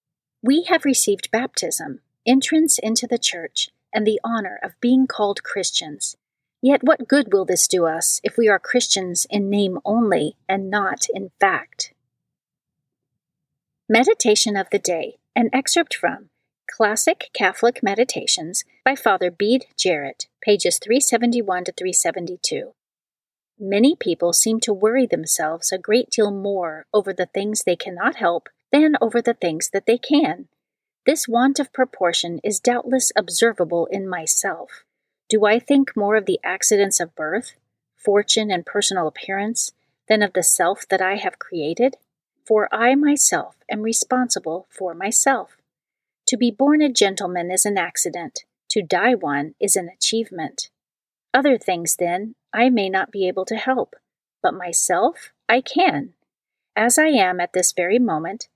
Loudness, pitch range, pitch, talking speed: -19 LUFS, 185-250 Hz, 215 Hz, 150 wpm